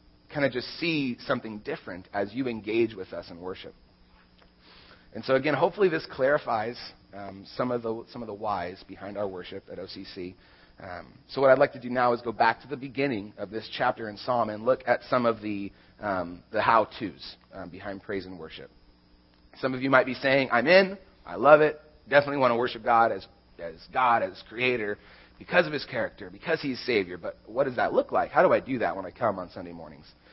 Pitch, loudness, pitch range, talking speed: 115 Hz, -26 LUFS, 95-130 Hz, 220 wpm